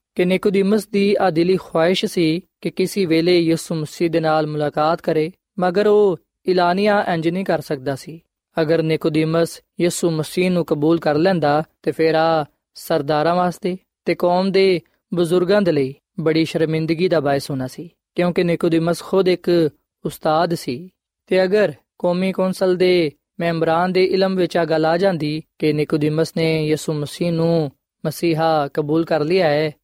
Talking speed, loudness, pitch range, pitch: 150 wpm, -19 LUFS, 155-185 Hz, 170 Hz